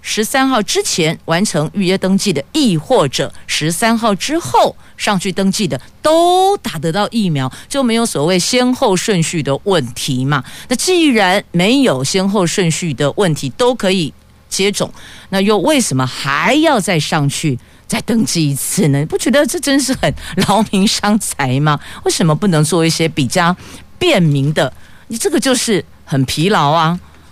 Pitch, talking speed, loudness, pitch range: 190 Hz, 245 characters per minute, -14 LUFS, 155-230 Hz